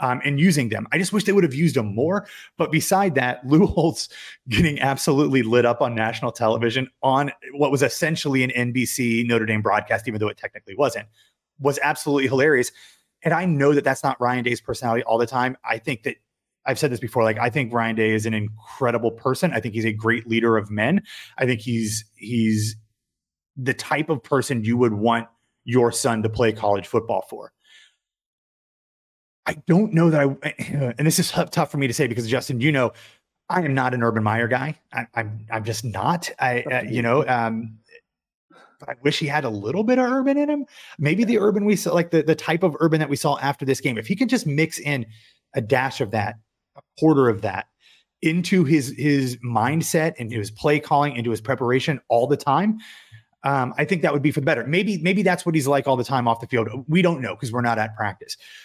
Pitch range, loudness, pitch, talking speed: 115-155 Hz, -22 LUFS, 135 Hz, 220 wpm